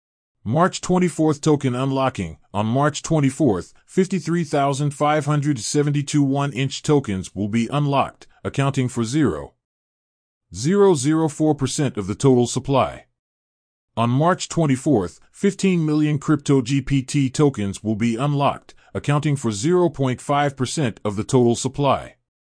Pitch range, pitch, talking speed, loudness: 115-150 Hz, 140 Hz, 110 wpm, -20 LUFS